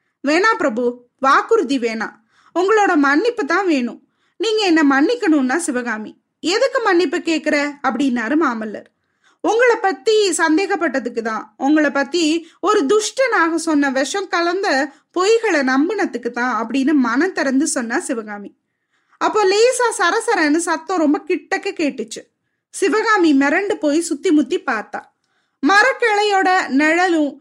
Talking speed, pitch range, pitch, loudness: 110 wpm, 275-390 Hz, 320 Hz, -17 LUFS